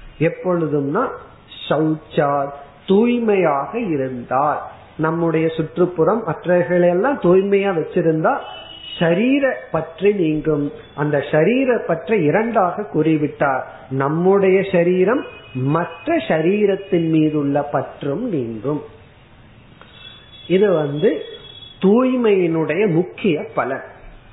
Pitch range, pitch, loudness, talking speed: 150-190 Hz, 165 Hz, -18 LUFS, 70 wpm